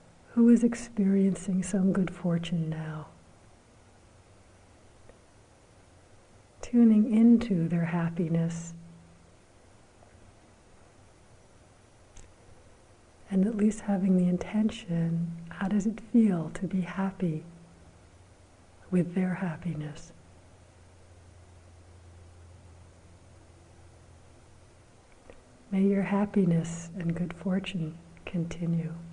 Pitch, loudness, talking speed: 150 Hz, -28 LUFS, 70 wpm